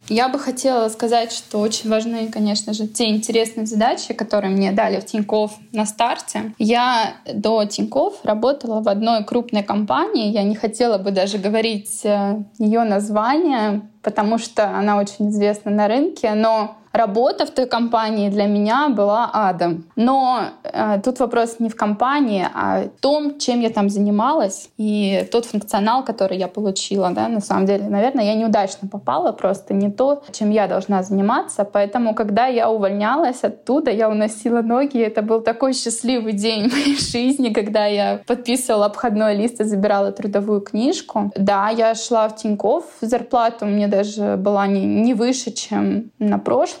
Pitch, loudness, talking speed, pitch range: 220 Hz, -19 LUFS, 165 wpm, 205-235 Hz